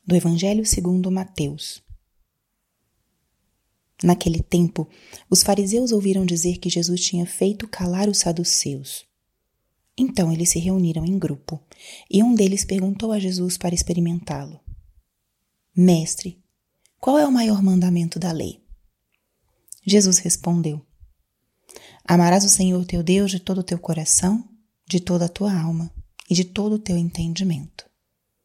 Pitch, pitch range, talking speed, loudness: 180 Hz, 170-195 Hz, 130 wpm, -20 LUFS